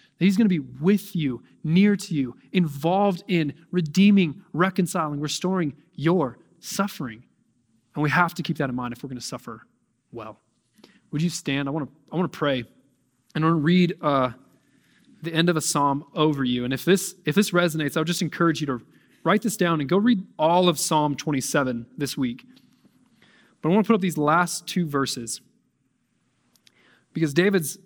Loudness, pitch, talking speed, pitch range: -23 LUFS, 160 Hz, 190 wpm, 140-185 Hz